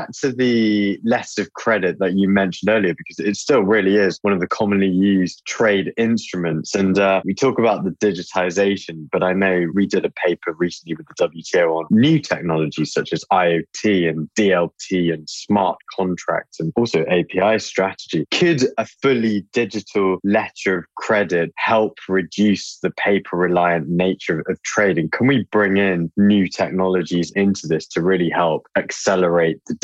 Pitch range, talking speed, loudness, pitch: 90-105 Hz, 165 wpm, -19 LUFS, 95 Hz